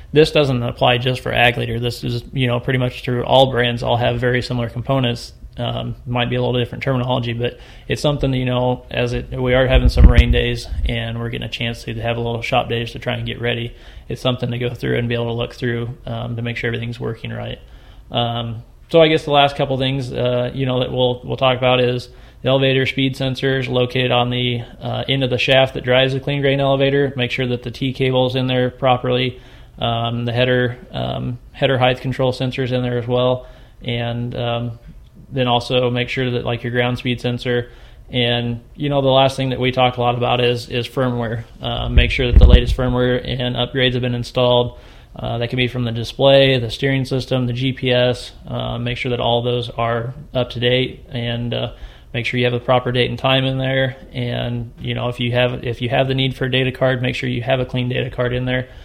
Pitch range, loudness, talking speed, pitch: 120-130 Hz, -18 LUFS, 235 wpm, 125 Hz